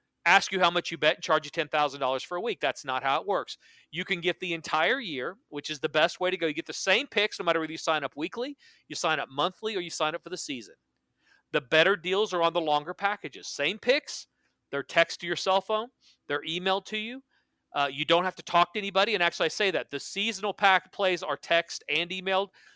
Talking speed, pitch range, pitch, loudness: 250 wpm, 155-195 Hz, 175 Hz, -28 LUFS